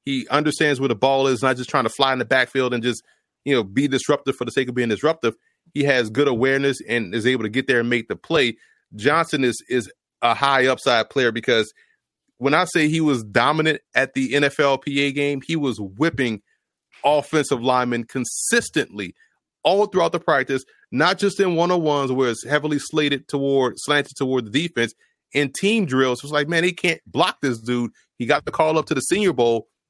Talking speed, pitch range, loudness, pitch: 205 wpm, 125-150 Hz, -20 LUFS, 135 Hz